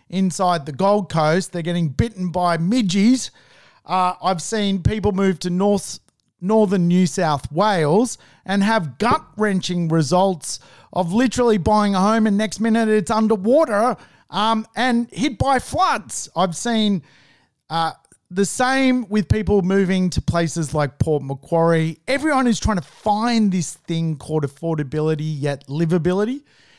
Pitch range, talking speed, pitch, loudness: 165-215 Hz, 145 wpm, 190 Hz, -19 LUFS